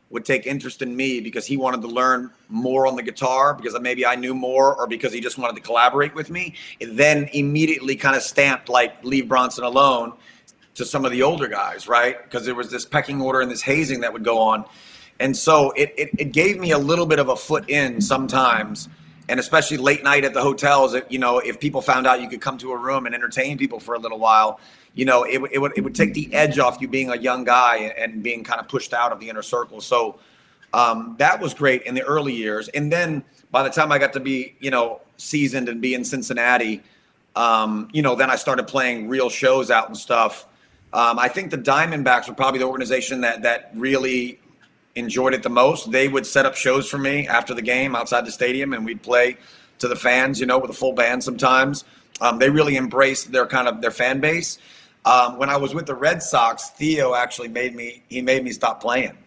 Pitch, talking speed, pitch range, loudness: 130 Hz, 235 wpm, 120-140 Hz, -20 LUFS